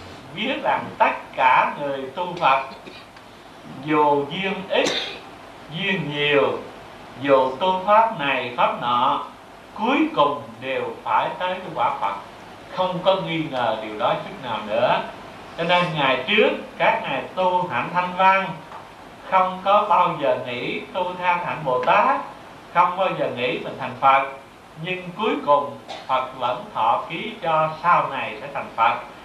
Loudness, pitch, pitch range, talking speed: -21 LUFS, 175 Hz, 135-185 Hz, 155 wpm